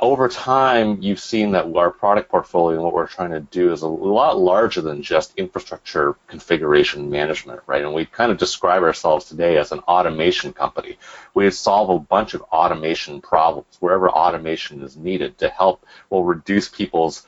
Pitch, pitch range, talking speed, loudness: 85 Hz, 80-100 Hz, 175 wpm, -19 LUFS